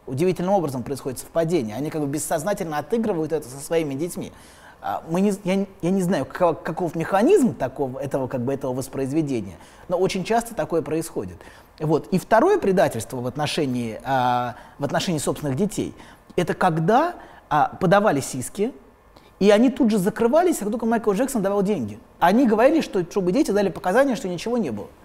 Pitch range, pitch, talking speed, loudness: 145-210 Hz, 175 Hz, 165 wpm, -22 LUFS